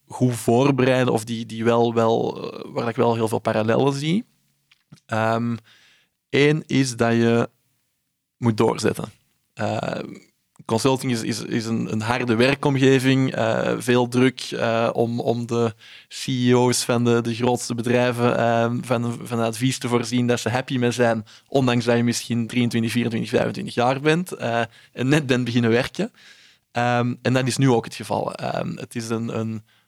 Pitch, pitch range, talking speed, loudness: 120 Hz, 115-130 Hz, 165 wpm, -22 LUFS